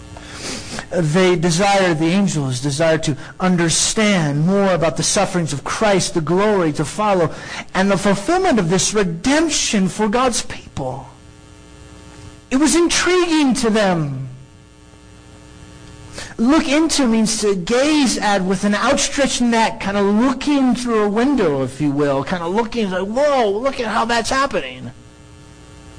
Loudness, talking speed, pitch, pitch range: -17 LUFS, 140 wpm, 200 Hz, 170-245 Hz